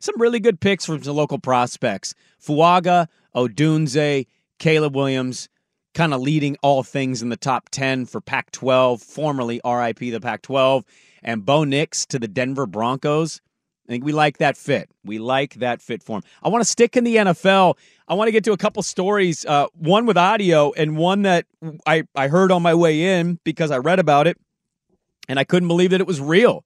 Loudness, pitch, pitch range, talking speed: -19 LUFS, 155 Hz, 135-185 Hz, 200 wpm